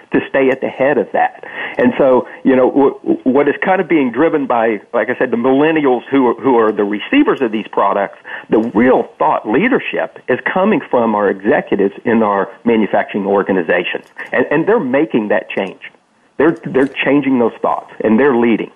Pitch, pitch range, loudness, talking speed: 135 Hz, 115-165 Hz, -14 LUFS, 190 wpm